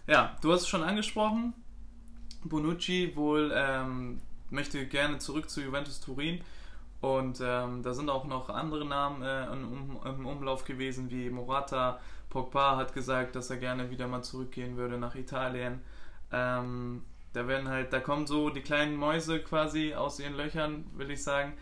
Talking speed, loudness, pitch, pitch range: 160 wpm, -33 LUFS, 135 Hz, 125-150 Hz